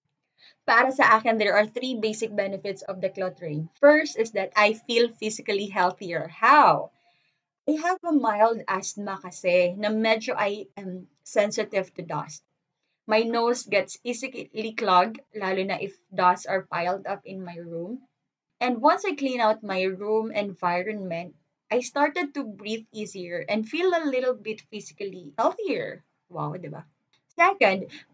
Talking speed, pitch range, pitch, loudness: 150 wpm, 185-235 Hz, 210 Hz, -25 LUFS